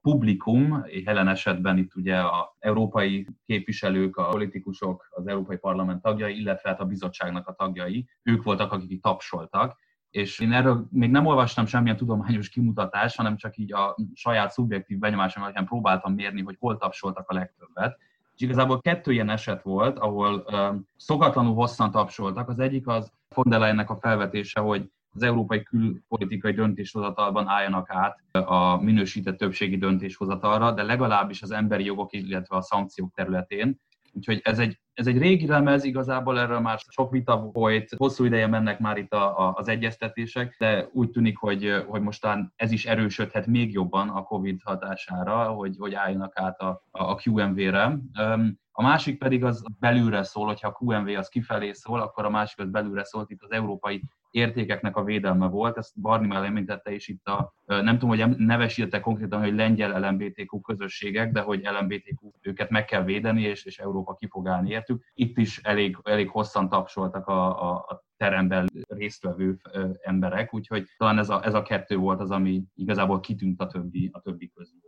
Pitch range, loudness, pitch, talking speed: 100-115 Hz, -26 LUFS, 105 Hz, 170 wpm